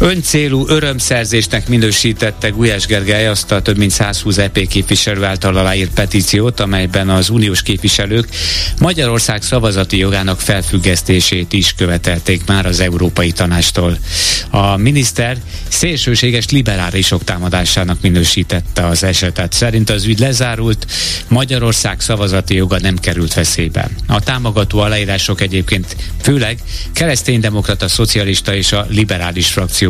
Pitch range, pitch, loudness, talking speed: 90-115 Hz, 100 Hz, -13 LUFS, 115 wpm